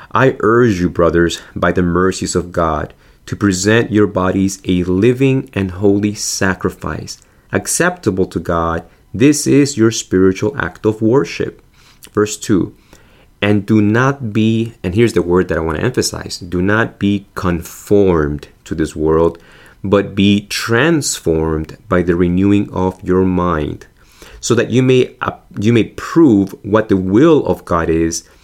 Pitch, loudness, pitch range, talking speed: 95 Hz, -15 LUFS, 90-110 Hz, 155 wpm